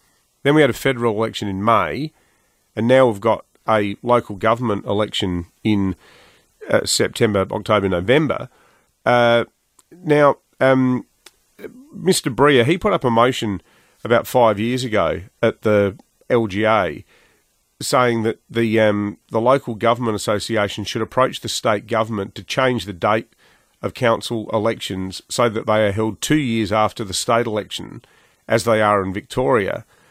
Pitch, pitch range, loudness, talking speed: 115 Hz, 105-125 Hz, -19 LUFS, 145 wpm